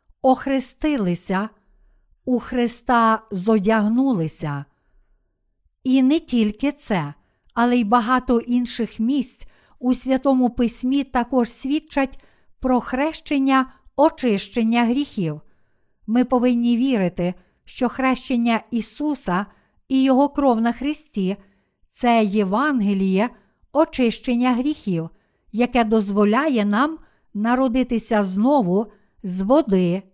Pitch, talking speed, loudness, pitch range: 240 Hz, 90 wpm, -20 LUFS, 205-260 Hz